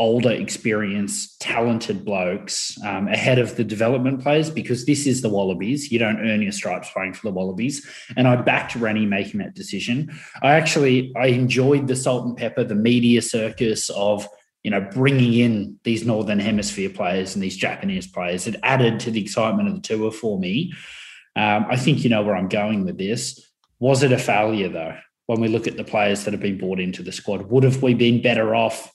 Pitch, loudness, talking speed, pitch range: 115 Hz, -21 LUFS, 205 wpm, 105-130 Hz